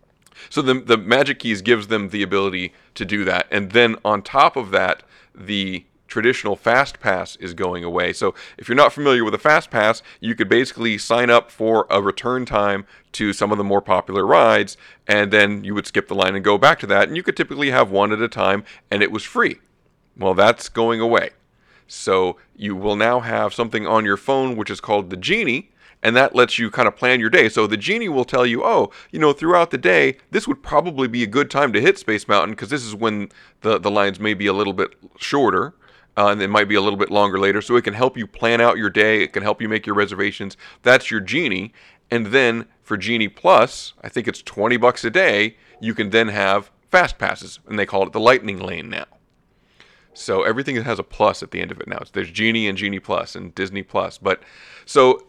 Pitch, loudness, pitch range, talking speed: 105 Hz, -18 LUFS, 100-115 Hz, 235 wpm